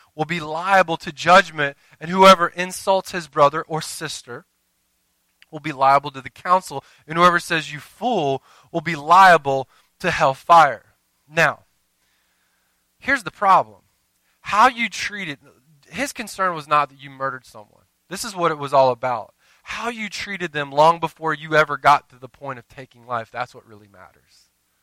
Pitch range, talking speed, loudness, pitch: 130-175 Hz, 170 wpm, -19 LUFS, 150 Hz